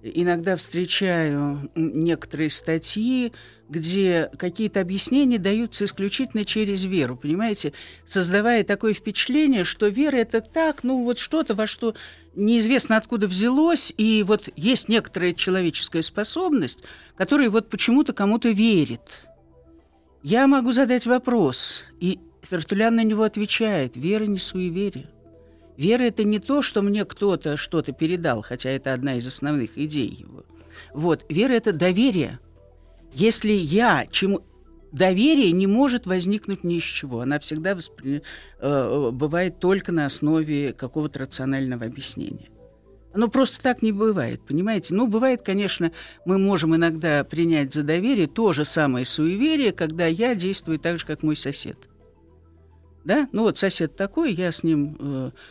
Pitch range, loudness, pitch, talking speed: 150-220 Hz, -22 LUFS, 185 Hz, 135 wpm